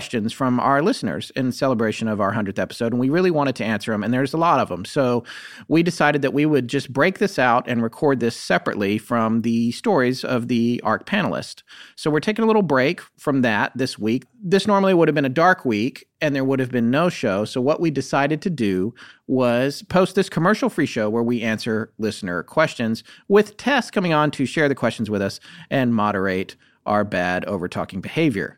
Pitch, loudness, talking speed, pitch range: 130 Hz, -21 LUFS, 215 wpm, 115-155 Hz